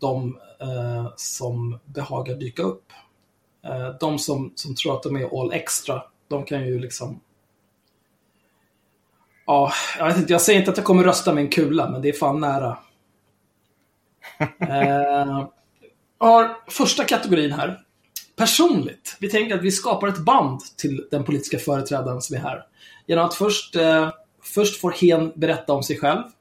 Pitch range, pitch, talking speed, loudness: 130-175 Hz, 145 Hz, 160 wpm, -21 LUFS